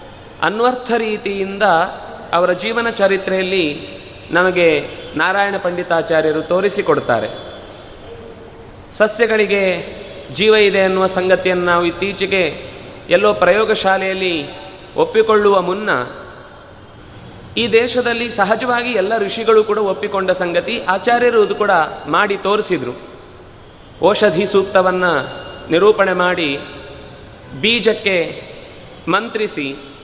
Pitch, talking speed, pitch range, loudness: 195 Hz, 75 wpm, 180-215 Hz, -15 LUFS